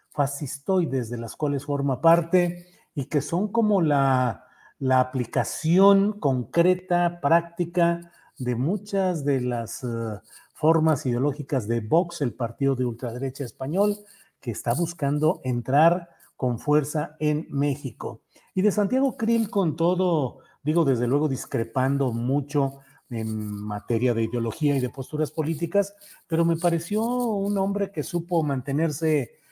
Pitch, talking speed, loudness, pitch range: 145 Hz, 130 wpm, -25 LUFS, 130-175 Hz